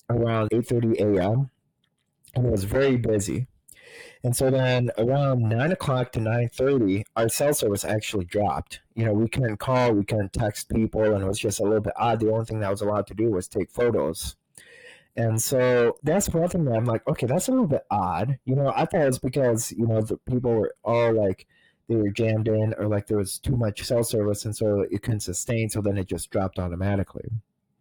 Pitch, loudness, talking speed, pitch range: 115 Hz, -24 LUFS, 220 wpm, 105-125 Hz